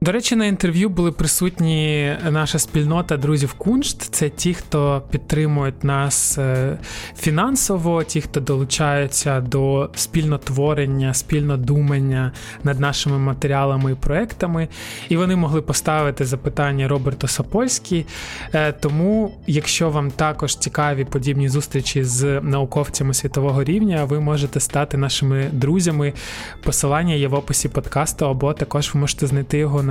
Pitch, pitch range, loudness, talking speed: 145 Hz, 140-155 Hz, -19 LUFS, 125 wpm